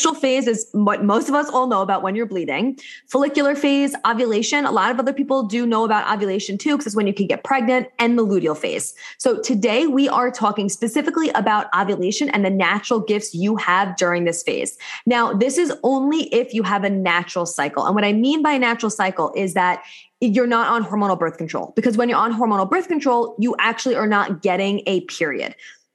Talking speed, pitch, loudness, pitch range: 215 wpm, 225 Hz, -19 LUFS, 200-260 Hz